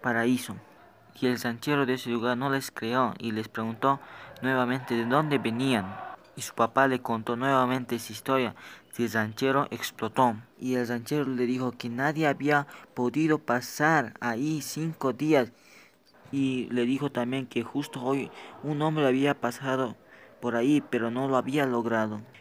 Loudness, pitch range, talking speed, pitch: -28 LUFS, 120-140 Hz, 160 wpm, 130 Hz